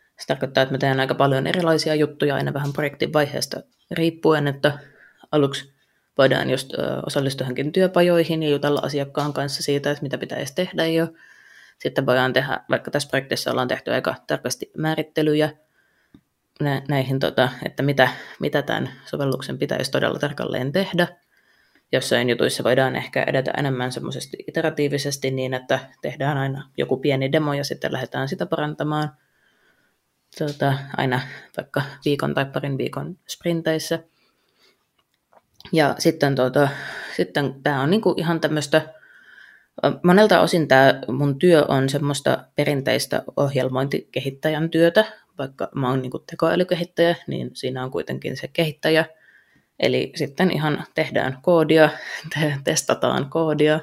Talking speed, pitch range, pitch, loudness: 130 wpm, 135-160 Hz, 145 Hz, -22 LUFS